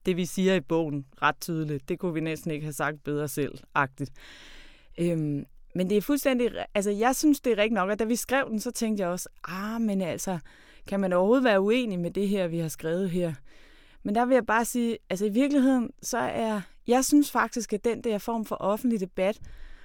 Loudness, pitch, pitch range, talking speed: -27 LUFS, 195 Hz, 170-230 Hz, 220 wpm